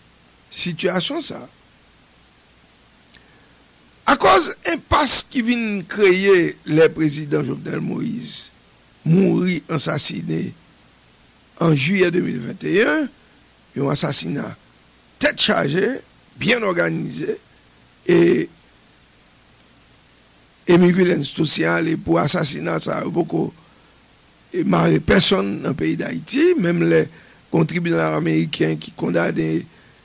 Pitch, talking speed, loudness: 160 Hz, 90 wpm, -18 LUFS